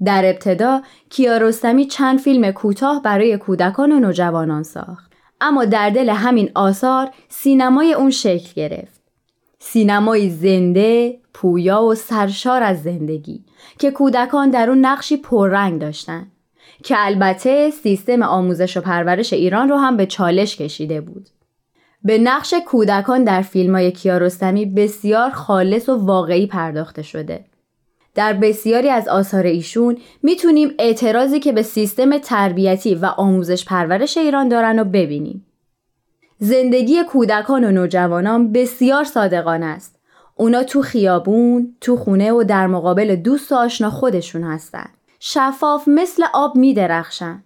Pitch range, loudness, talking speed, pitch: 185-255 Hz, -16 LUFS, 130 wpm, 215 Hz